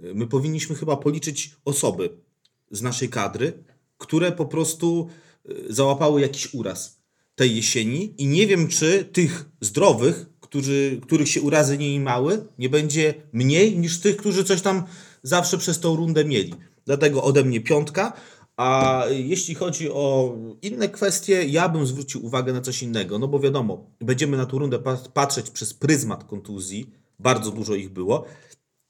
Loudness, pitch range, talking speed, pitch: -22 LUFS, 130-165 Hz, 155 wpm, 145 Hz